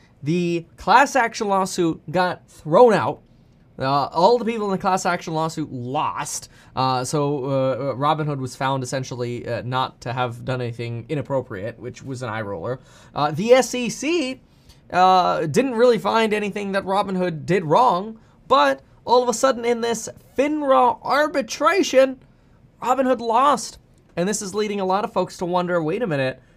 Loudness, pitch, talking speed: -21 LUFS, 180 Hz, 170 wpm